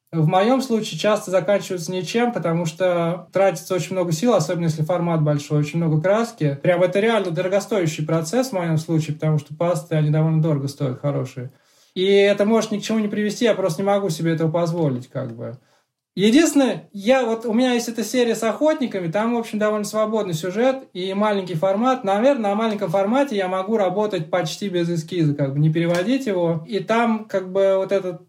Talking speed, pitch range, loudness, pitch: 195 wpm, 165-215 Hz, -20 LUFS, 190 Hz